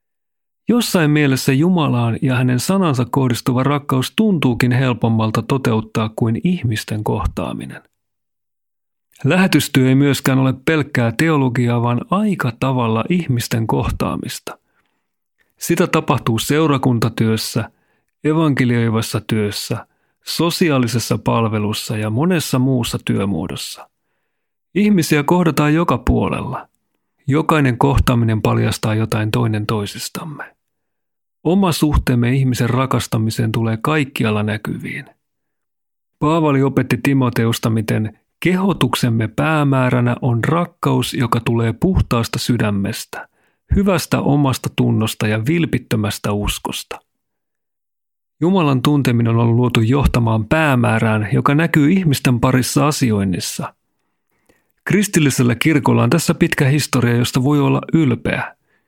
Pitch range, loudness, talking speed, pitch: 115-150 Hz, -17 LUFS, 95 wpm, 130 Hz